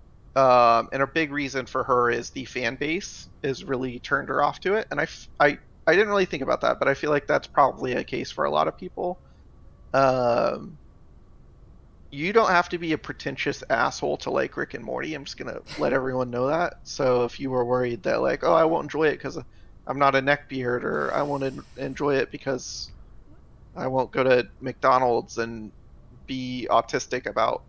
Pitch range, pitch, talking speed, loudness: 120-140 Hz, 130 Hz, 205 wpm, -24 LUFS